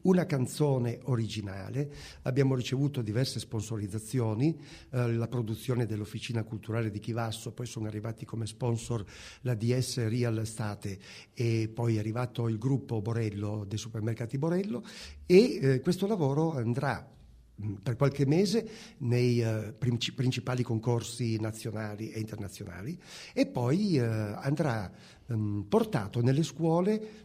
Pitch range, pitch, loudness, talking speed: 110-135 Hz, 120 Hz, -31 LUFS, 125 wpm